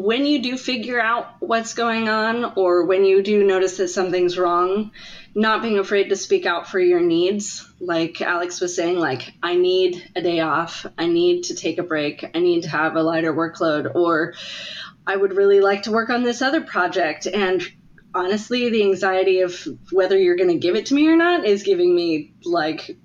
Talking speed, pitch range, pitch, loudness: 205 wpm, 180-235 Hz, 195 Hz, -20 LUFS